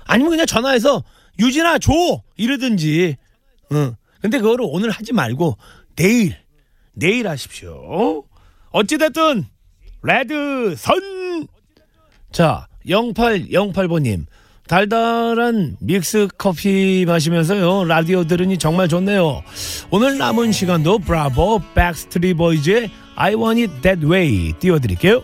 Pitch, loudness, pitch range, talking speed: 185 Hz, -17 LUFS, 155-230 Hz, 255 characters per minute